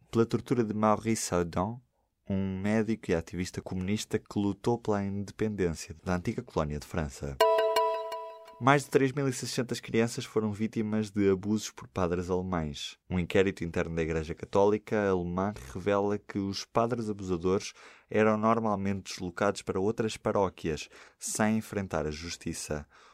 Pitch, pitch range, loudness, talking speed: 105 Hz, 90-110 Hz, -30 LUFS, 135 wpm